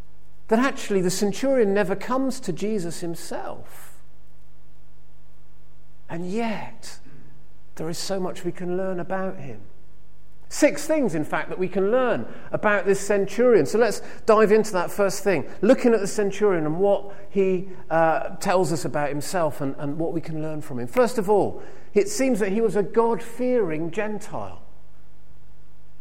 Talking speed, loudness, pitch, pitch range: 160 wpm, -23 LUFS, 195 Hz, 165-215 Hz